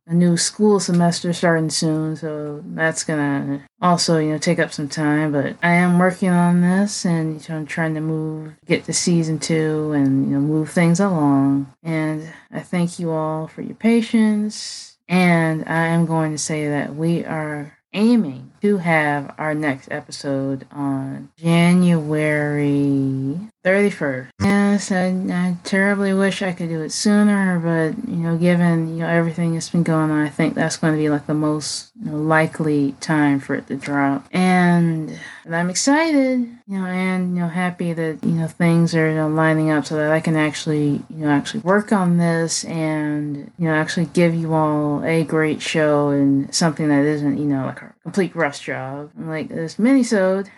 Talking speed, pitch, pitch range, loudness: 180 wpm, 160 Hz, 150-180 Hz, -19 LUFS